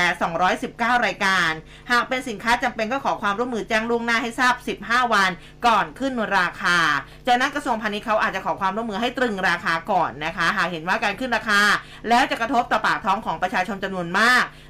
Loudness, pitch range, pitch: -21 LUFS, 195-245 Hz, 225 Hz